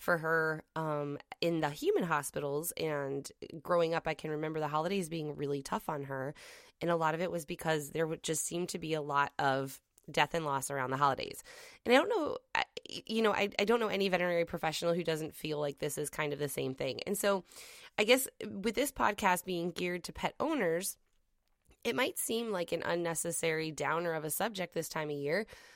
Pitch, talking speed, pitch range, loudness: 165 Hz, 210 wpm, 150-195 Hz, -34 LUFS